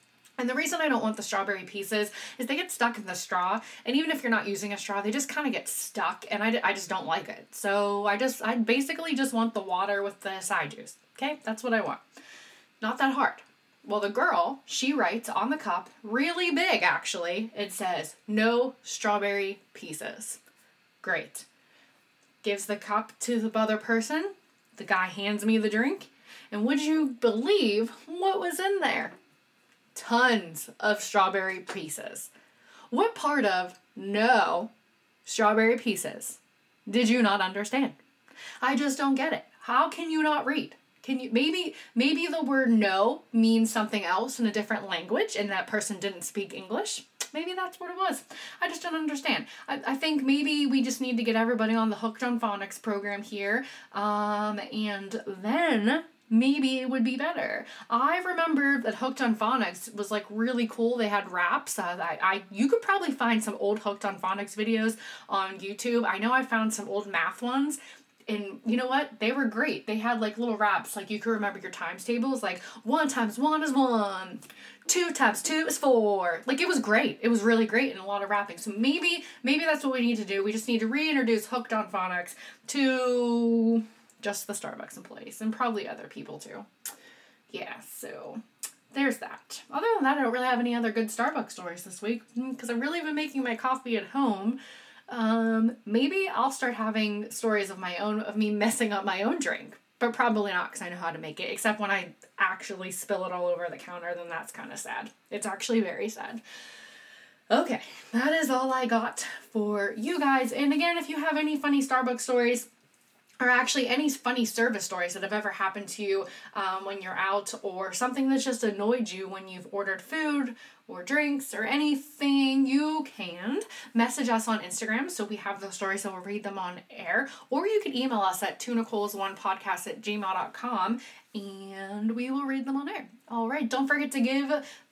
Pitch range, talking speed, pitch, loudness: 205-265 Hz, 195 wpm, 230 Hz, -28 LUFS